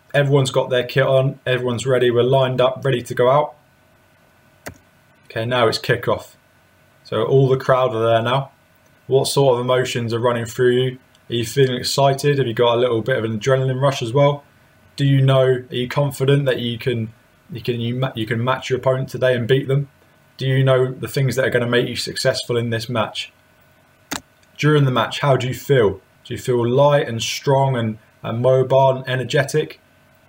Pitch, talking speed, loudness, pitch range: 130 Hz, 200 wpm, -18 LUFS, 120-135 Hz